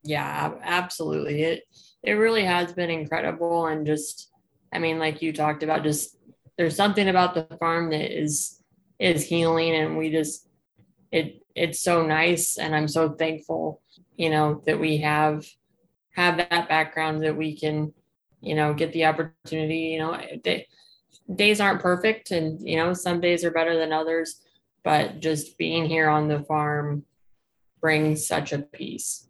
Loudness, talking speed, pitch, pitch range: -24 LUFS, 160 wpm, 160 Hz, 155-170 Hz